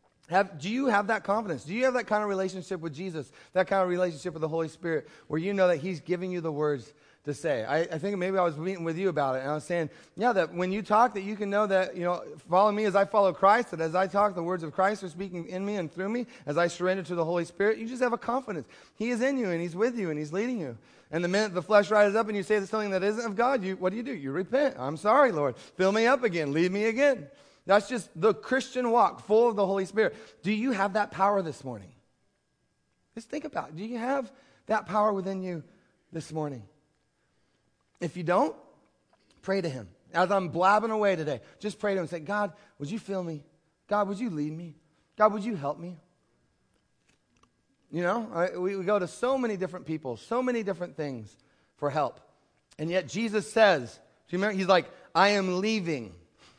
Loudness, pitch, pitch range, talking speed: -28 LUFS, 190 Hz, 165-215 Hz, 245 wpm